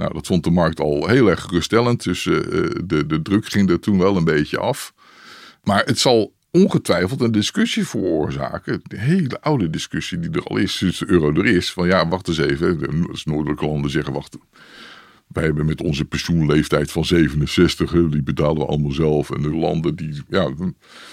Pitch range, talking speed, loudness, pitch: 75-100 Hz, 195 wpm, -19 LUFS, 85 Hz